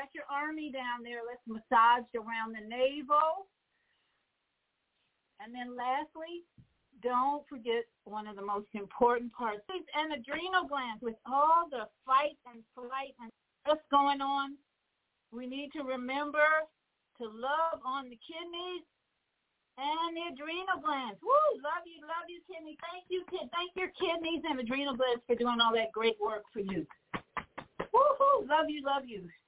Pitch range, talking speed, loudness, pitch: 240-315 Hz, 150 wpm, -33 LUFS, 275 Hz